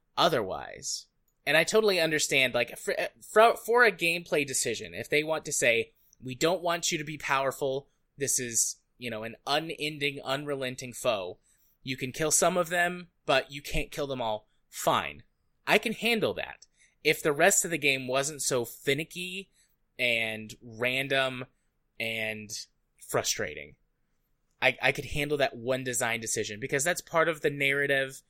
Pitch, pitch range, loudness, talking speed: 140 Hz, 125-160 Hz, -28 LUFS, 160 wpm